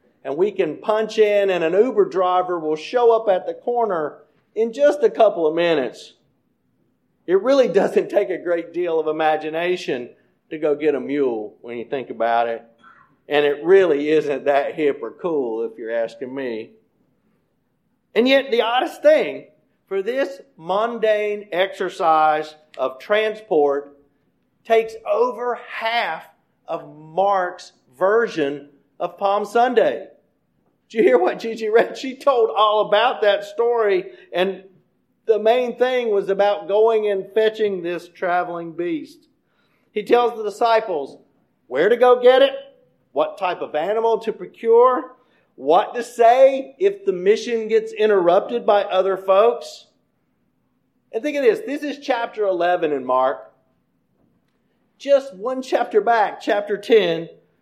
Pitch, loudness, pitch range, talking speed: 210 Hz, -19 LUFS, 175-245 Hz, 145 wpm